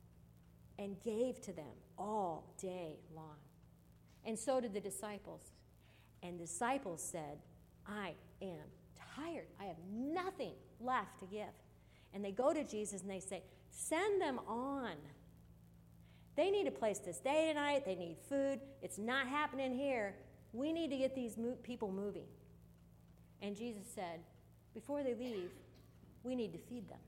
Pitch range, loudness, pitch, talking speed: 170-255 Hz, -42 LUFS, 210 Hz, 150 wpm